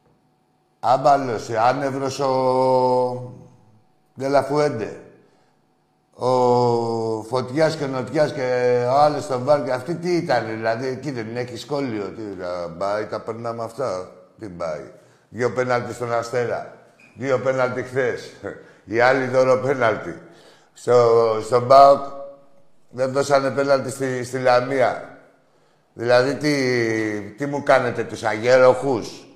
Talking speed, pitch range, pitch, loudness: 115 wpm, 115-135 Hz, 125 Hz, -20 LUFS